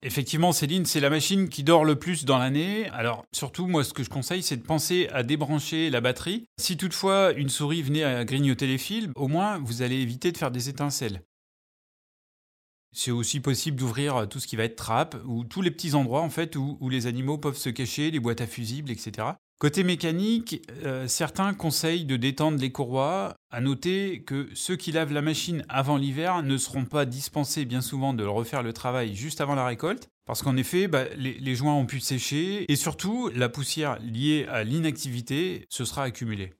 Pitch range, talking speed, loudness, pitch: 125-160 Hz, 205 wpm, -27 LUFS, 140 Hz